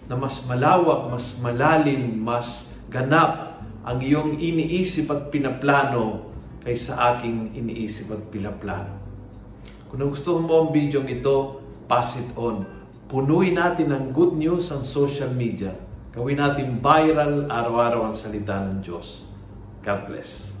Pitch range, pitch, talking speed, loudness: 110-145 Hz, 125 Hz, 130 wpm, -23 LUFS